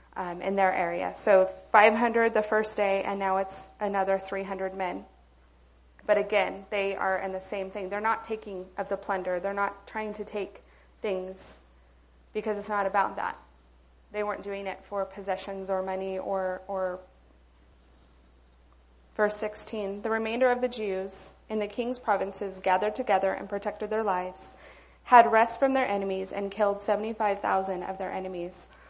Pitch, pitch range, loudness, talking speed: 195 Hz, 185-210 Hz, -28 LUFS, 160 wpm